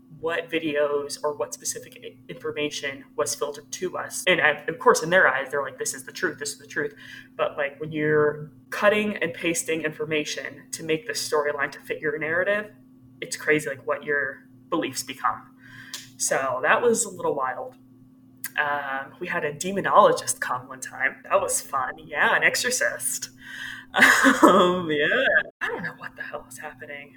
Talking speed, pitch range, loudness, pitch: 175 wpm, 145-180 Hz, -24 LUFS, 150 Hz